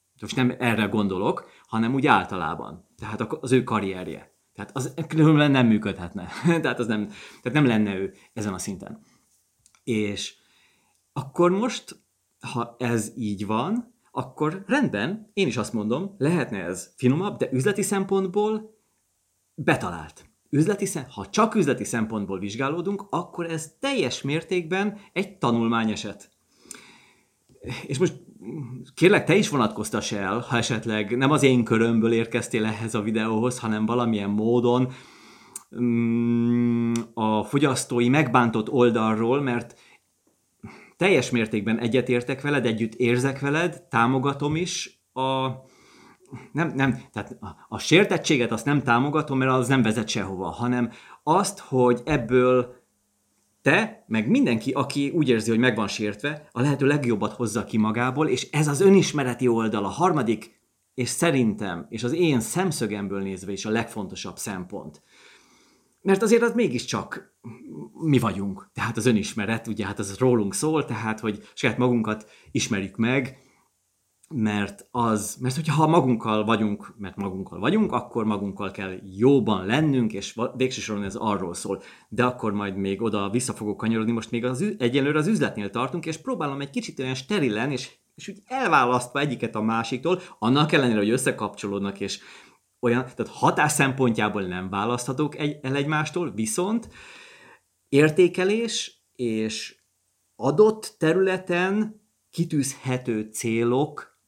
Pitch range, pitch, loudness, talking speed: 110-150 Hz, 125 Hz, -24 LUFS, 135 wpm